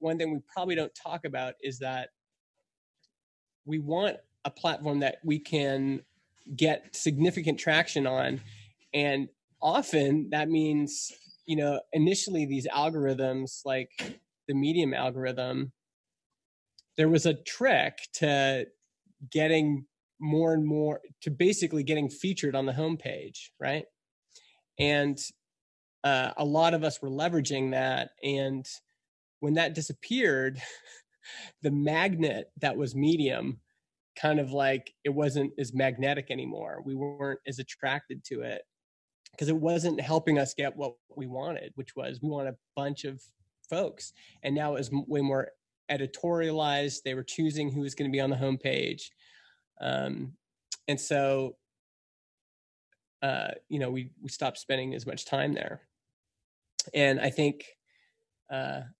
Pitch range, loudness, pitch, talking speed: 135-155 Hz, -30 LUFS, 145 Hz, 135 wpm